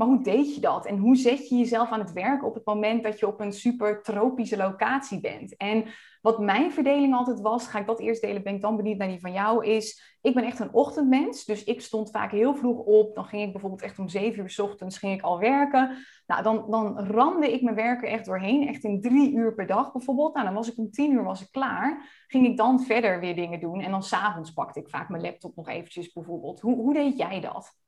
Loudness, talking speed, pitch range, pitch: -26 LUFS, 255 wpm, 205-255 Hz, 220 Hz